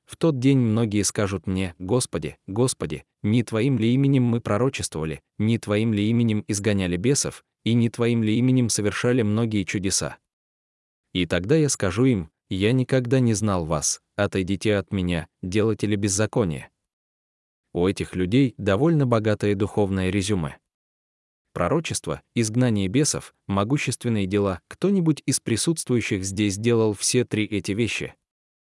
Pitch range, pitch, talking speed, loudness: 95-120 Hz, 105 Hz, 135 wpm, -23 LUFS